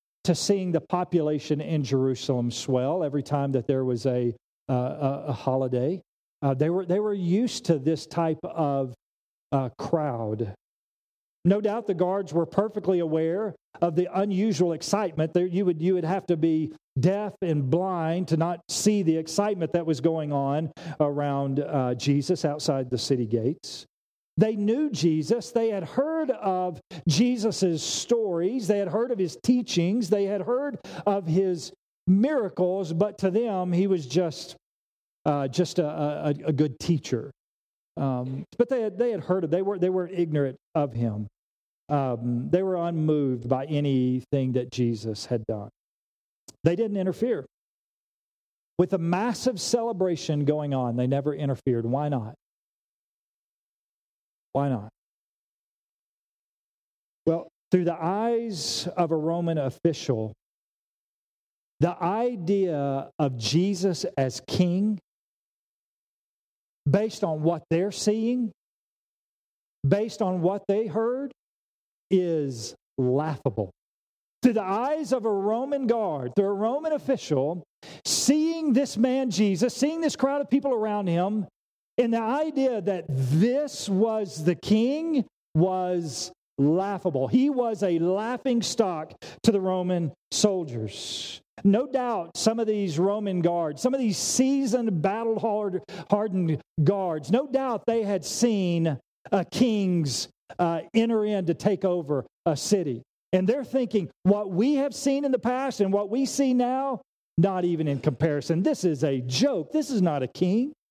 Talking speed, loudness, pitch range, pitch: 145 wpm, -26 LUFS, 150-215 Hz, 180 Hz